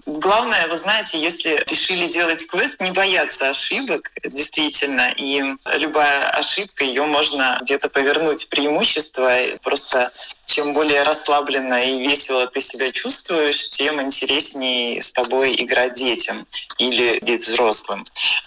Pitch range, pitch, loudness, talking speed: 130-155 Hz, 145 Hz, -17 LUFS, 125 wpm